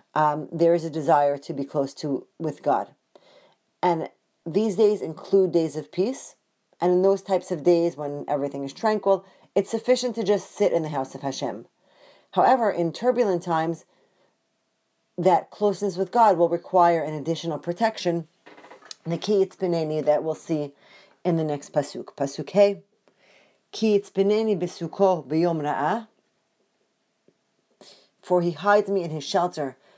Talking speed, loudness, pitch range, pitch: 150 wpm, -24 LUFS, 155-200 Hz, 175 Hz